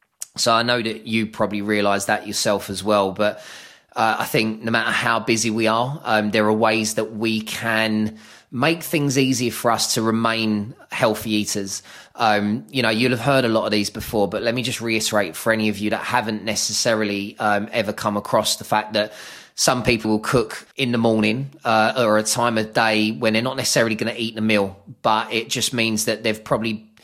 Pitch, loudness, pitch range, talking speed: 110 Hz, -20 LUFS, 105-115 Hz, 215 wpm